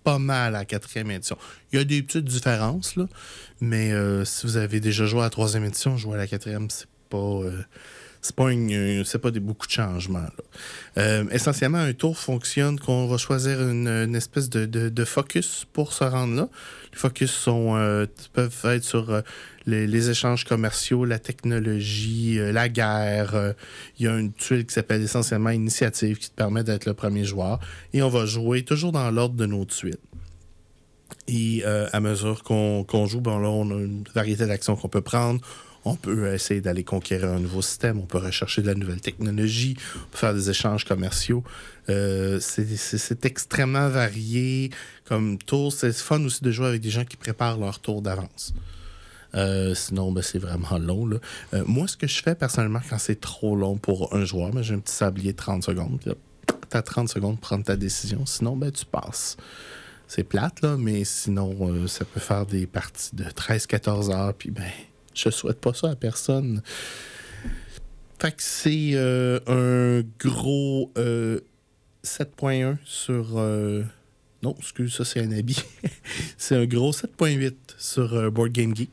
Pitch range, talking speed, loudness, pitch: 100-125 Hz, 190 wpm, -25 LUFS, 110 Hz